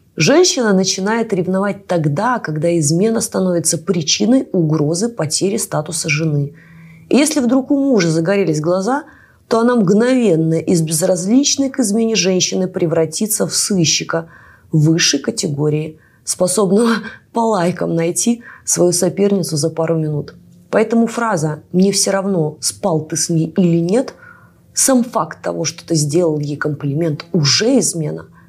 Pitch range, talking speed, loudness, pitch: 160-220 Hz, 130 wpm, -15 LUFS, 180 Hz